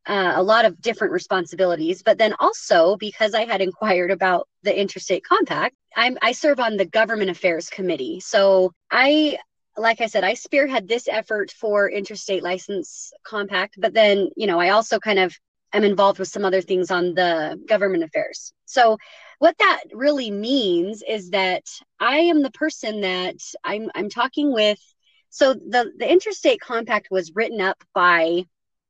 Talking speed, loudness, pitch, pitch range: 170 wpm, -20 LUFS, 210 Hz, 190-255 Hz